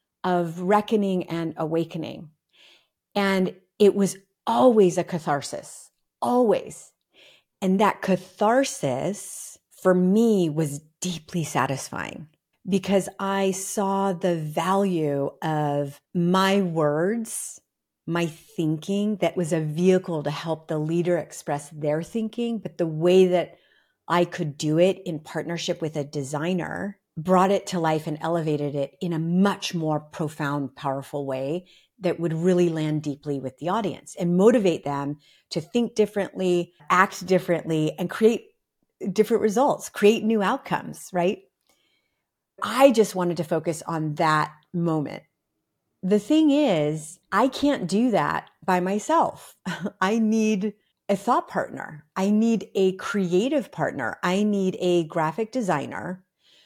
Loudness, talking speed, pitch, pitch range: -24 LUFS, 130 wpm, 180 Hz, 160-200 Hz